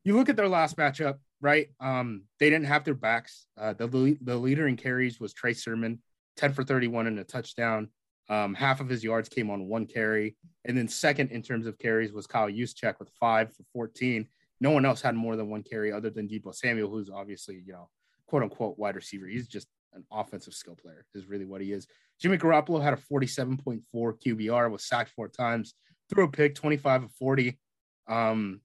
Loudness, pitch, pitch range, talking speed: -29 LUFS, 115 Hz, 110-135 Hz, 205 wpm